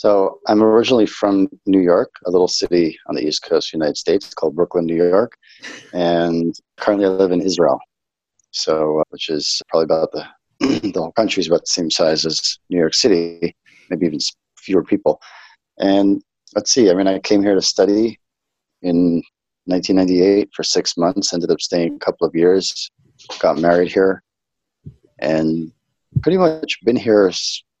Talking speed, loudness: 170 wpm, -17 LUFS